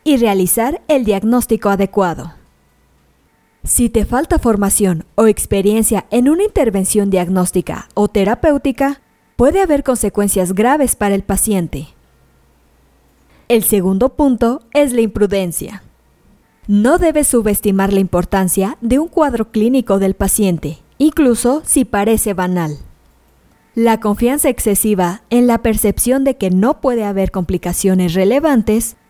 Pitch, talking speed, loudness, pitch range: 210 Hz, 120 wpm, -14 LUFS, 185-245 Hz